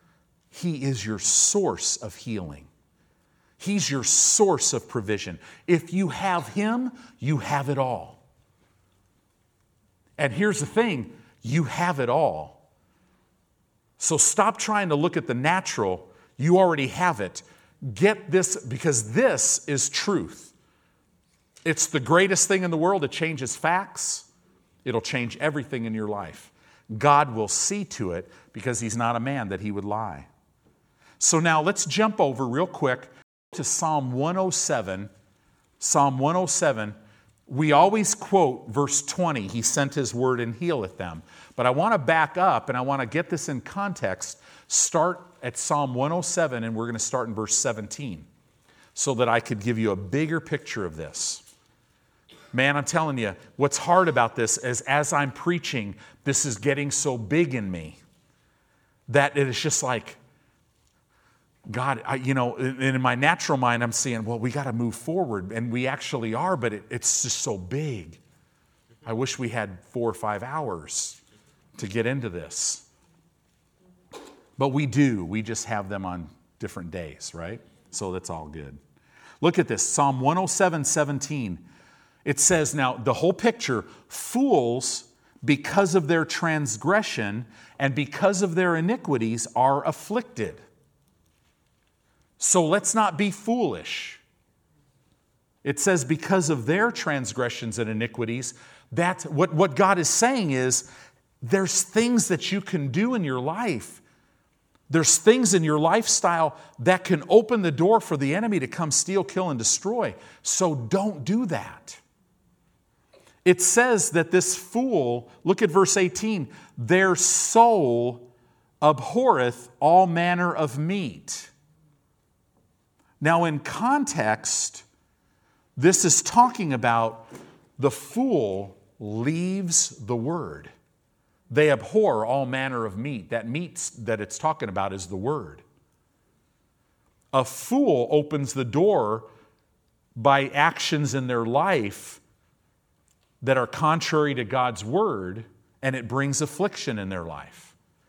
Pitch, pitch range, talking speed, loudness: 140 Hz, 115-175 Hz, 145 wpm, -24 LUFS